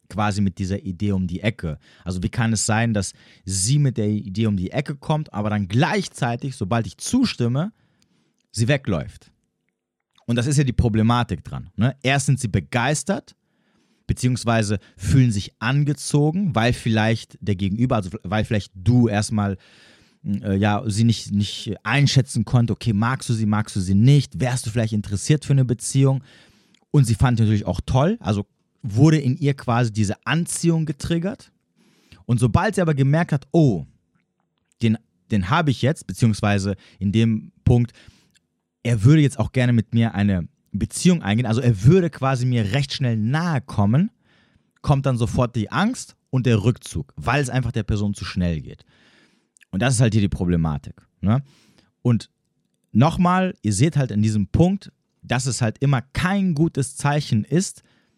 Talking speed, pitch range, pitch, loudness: 170 wpm, 105-140 Hz, 120 Hz, -21 LUFS